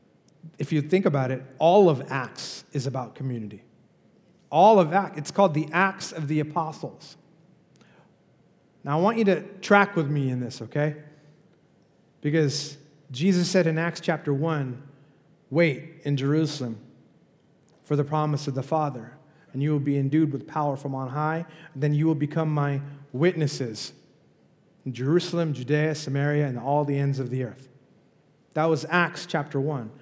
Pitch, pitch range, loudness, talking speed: 150 Hz, 140-165 Hz, -25 LUFS, 160 wpm